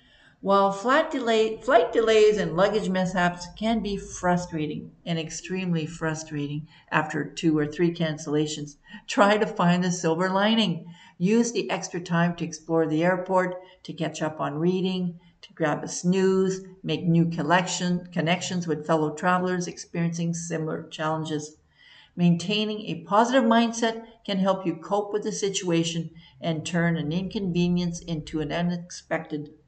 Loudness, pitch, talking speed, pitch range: -25 LUFS, 175 Hz, 140 wpm, 160-195 Hz